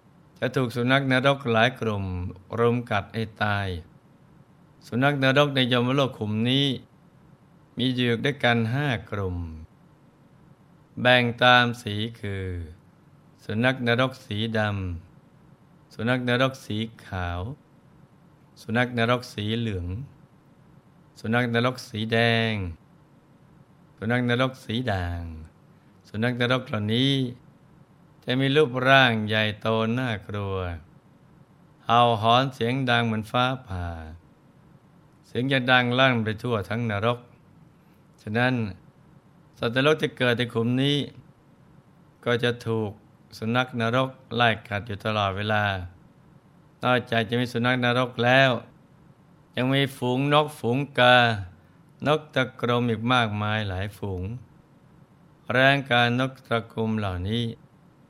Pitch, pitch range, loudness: 125 Hz, 110-145 Hz, -24 LUFS